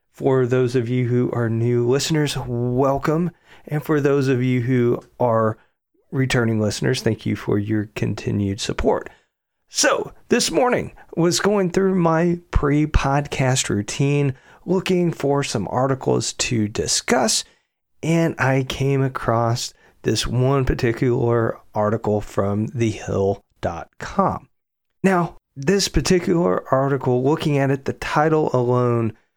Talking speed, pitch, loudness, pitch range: 125 wpm, 130 Hz, -20 LUFS, 115-150 Hz